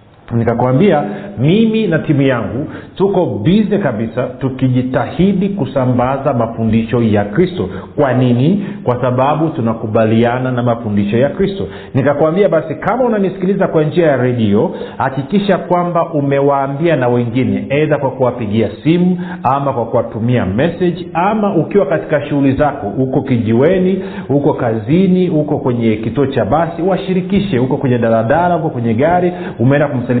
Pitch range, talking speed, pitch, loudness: 120-175 Hz, 125 wpm, 140 Hz, -14 LUFS